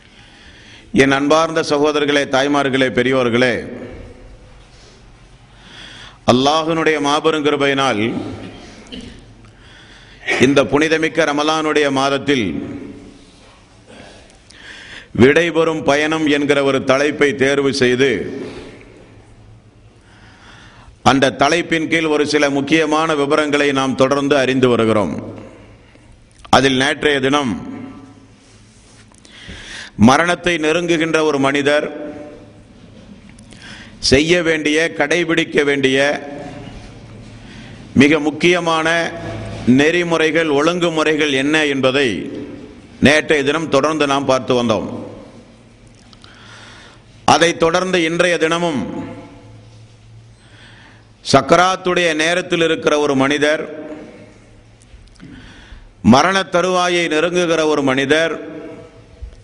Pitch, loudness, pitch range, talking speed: 140 Hz, -15 LUFS, 115-155 Hz, 70 wpm